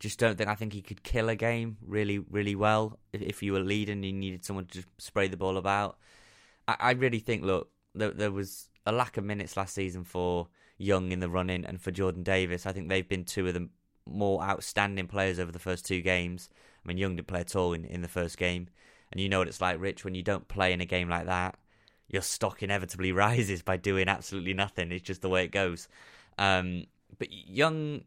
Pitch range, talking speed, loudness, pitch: 90-100 Hz, 235 wpm, -31 LUFS, 95 Hz